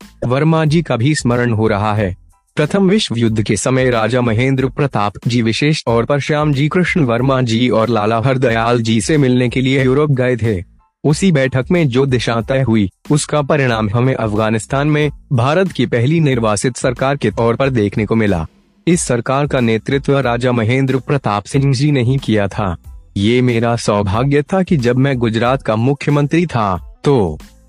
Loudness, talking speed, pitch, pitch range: -15 LUFS, 180 wpm, 125 Hz, 115-145 Hz